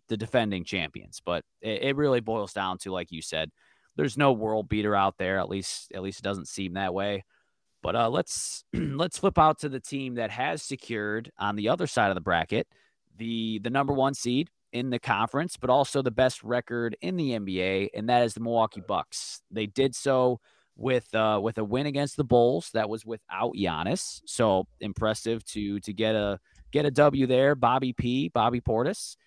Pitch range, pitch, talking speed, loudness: 105-130 Hz, 115 Hz, 200 wpm, -28 LUFS